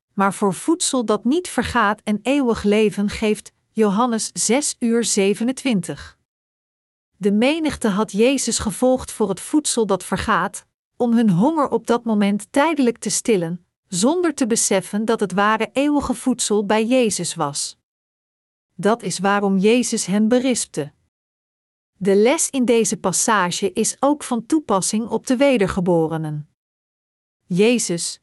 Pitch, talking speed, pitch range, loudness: 215 Hz, 130 wpm, 195-245 Hz, -19 LUFS